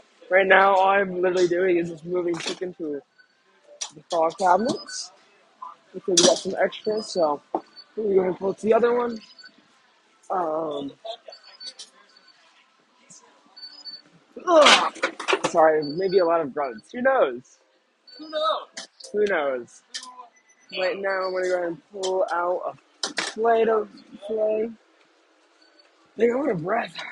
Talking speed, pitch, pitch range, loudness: 130 wpm, 195 Hz, 180-240 Hz, -23 LUFS